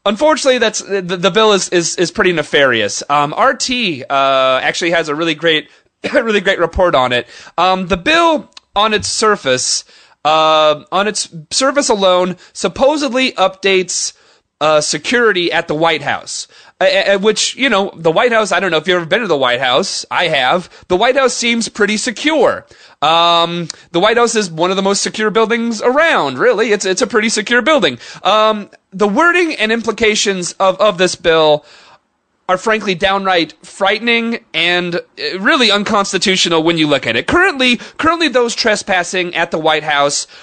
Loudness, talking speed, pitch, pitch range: -13 LUFS, 170 wpm, 195 Hz, 170-230 Hz